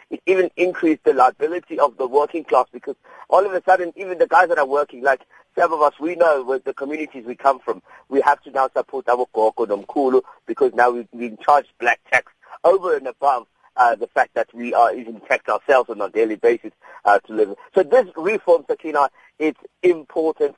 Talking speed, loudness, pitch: 205 wpm, -19 LUFS, 165 Hz